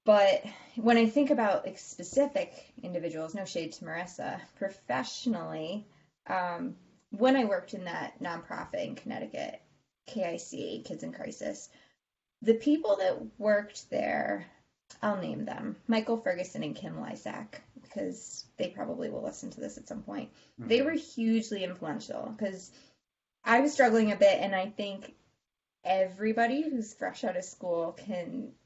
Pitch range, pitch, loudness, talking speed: 190-260 Hz, 220 Hz, -31 LUFS, 140 wpm